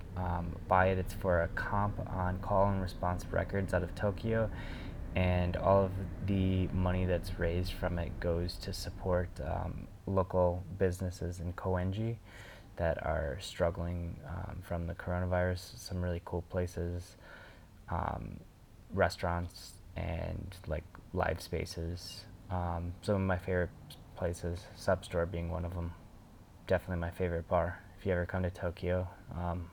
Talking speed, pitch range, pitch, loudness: 145 wpm, 85-95 Hz, 90 Hz, -35 LUFS